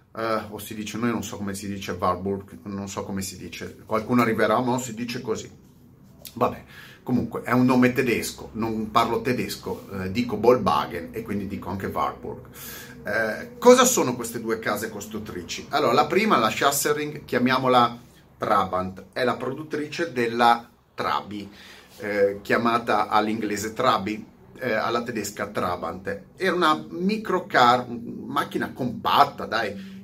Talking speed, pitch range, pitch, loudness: 145 wpm, 100-125 Hz, 115 Hz, -24 LUFS